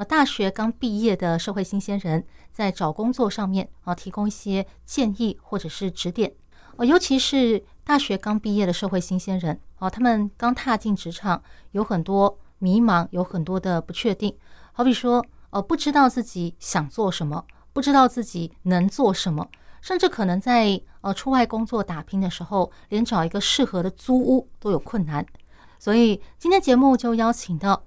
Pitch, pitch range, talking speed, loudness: 205 Hz, 185-235 Hz, 265 characters per minute, -23 LUFS